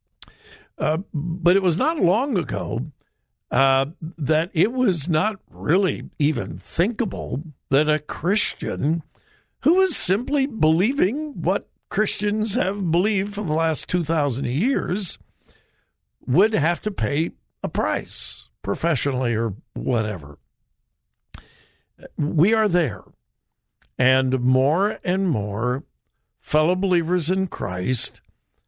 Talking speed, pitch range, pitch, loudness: 105 wpm, 135-190 Hz, 160 Hz, -22 LUFS